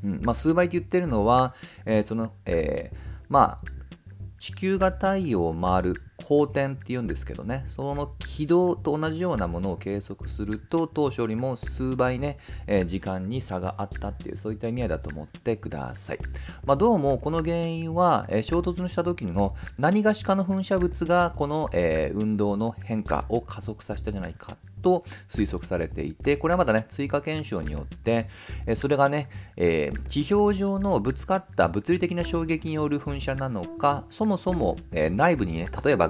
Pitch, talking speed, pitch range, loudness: 120 Hz, 355 characters per minute, 100-165 Hz, -26 LUFS